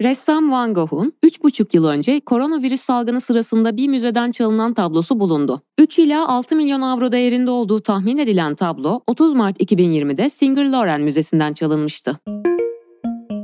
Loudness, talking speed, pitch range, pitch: -17 LUFS, 140 wpm, 170-265 Hz, 235 Hz